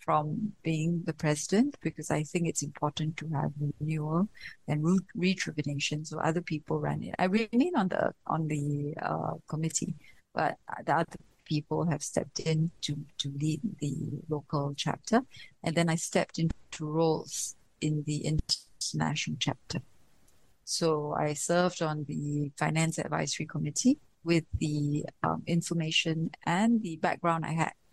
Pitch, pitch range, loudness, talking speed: 160 Hz, 150-170 Hz, -31 LUFS, 150 wpm